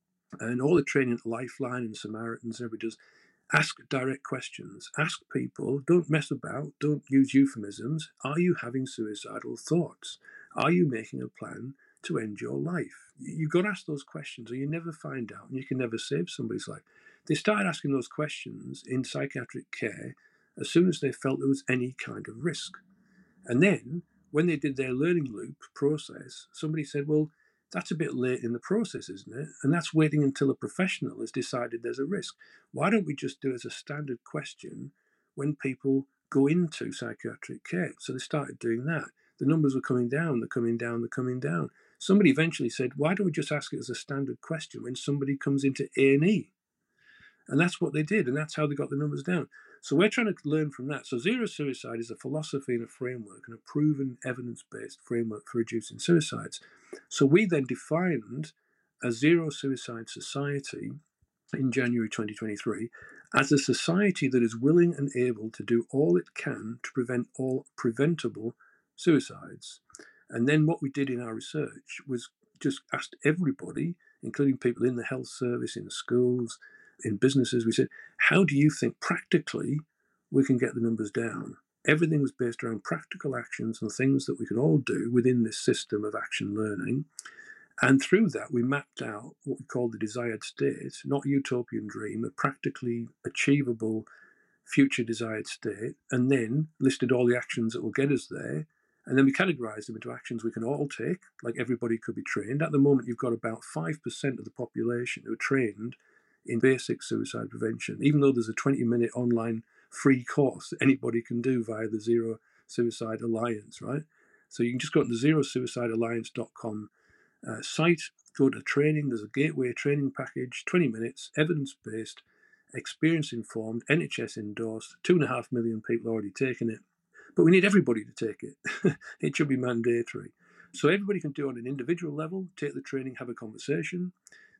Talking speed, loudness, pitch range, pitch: 185 wpm, -29 LUFS, 120-155 Hz, 135 Hz